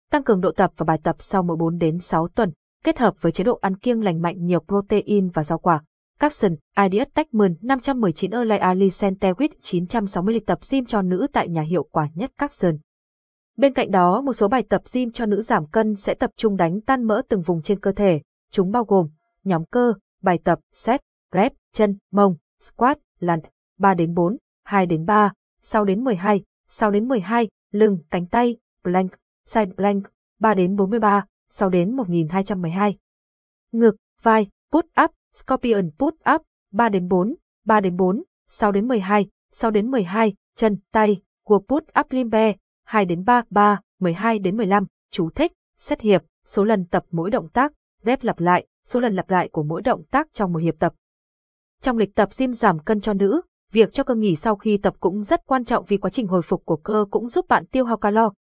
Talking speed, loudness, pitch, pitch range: 200 wpm, -21 LUFS, 205 Hz, 185-235 Hz